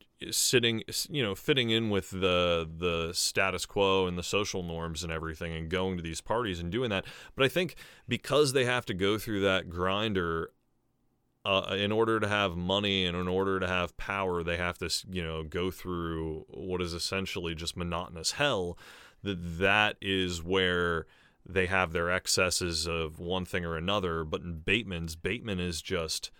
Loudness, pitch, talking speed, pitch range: -30 LUFS, 90 Hz, 180 wpm, 85-100 Hz